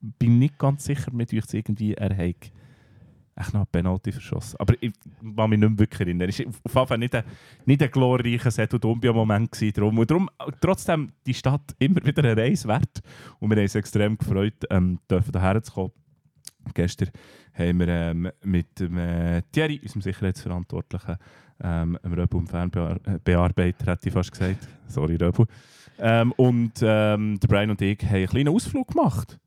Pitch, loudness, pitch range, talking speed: 110 Hz, -24 LUFS, 95-125 Hz, 155 wpm